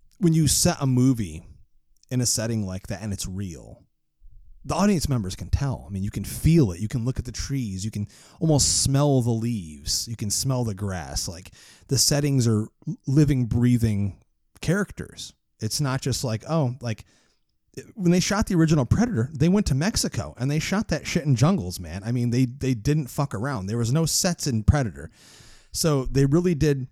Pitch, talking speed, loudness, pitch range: 125 Hz, 200 wpm, -24 LUFS, 105-150 Hz